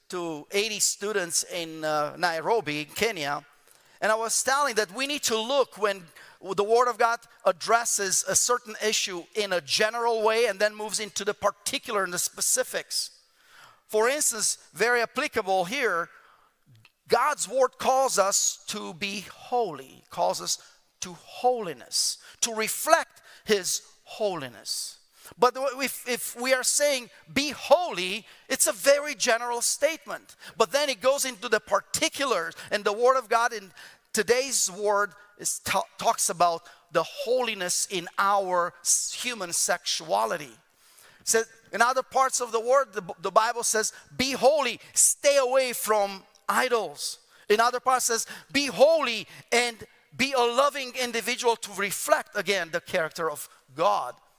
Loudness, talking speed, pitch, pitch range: -25 LUFS, 150 wpm, 225 Hz, 200-255 Hz